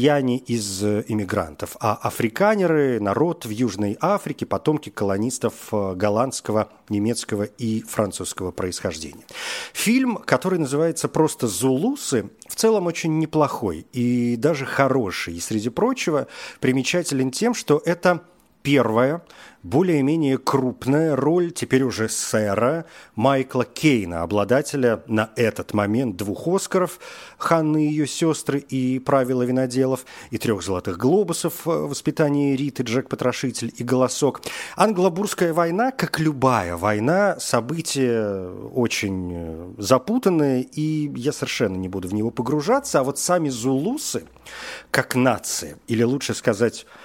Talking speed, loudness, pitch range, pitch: 115 wpm, -22 LUFS, 110-155 Hz, 130 Hz